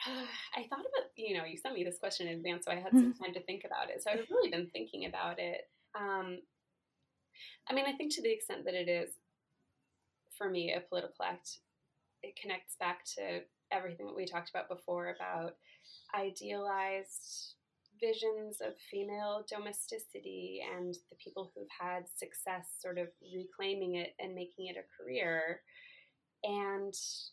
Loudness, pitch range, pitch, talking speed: -39 LUFS, 175-210 Hz, 185 Hz, 165 wpm